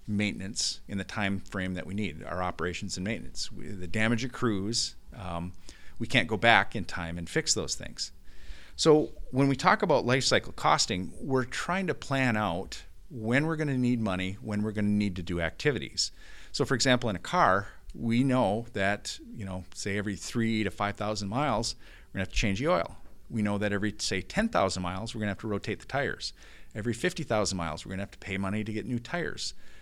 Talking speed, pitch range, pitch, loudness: 215 wpm, 95-115 Hz, 105 Hz, -29 LUFS